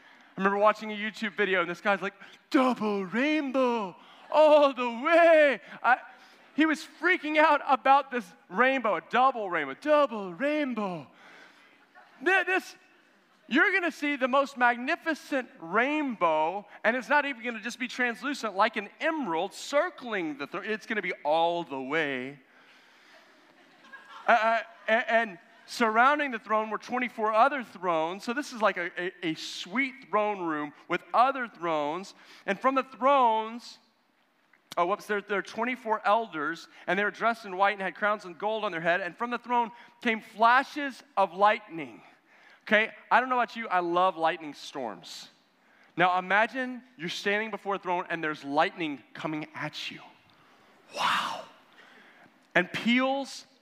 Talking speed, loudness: 155 wpm, -27 LUFS